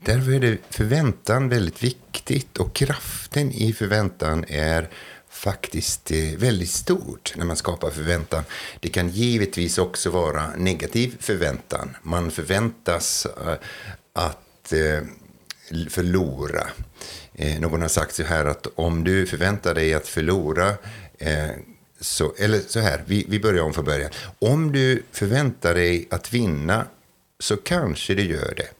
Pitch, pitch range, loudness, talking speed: 90 Hz, 80-110 Hz, -23 LUFS, 125 wpm